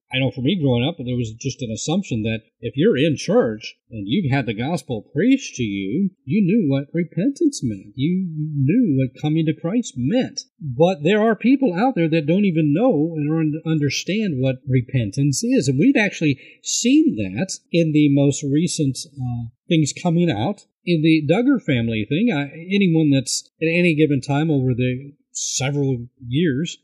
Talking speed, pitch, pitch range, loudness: 180 wpm, 155 Hz, 130-190 Hz, -20 LUFS